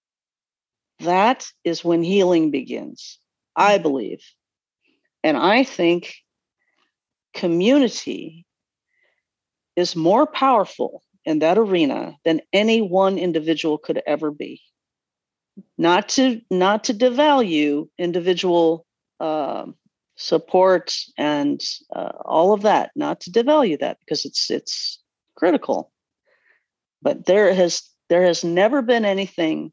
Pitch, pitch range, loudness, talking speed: 190 Hz, 170-265 Hz, -19 LUFS, 105 wpm